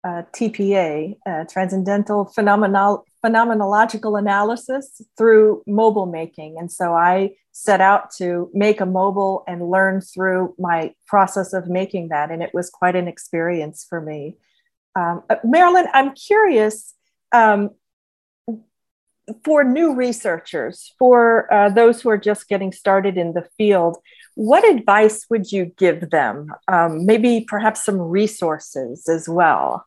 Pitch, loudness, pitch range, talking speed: 195 Hz, -17 LUFS, 175-220 Hz, 135 wpm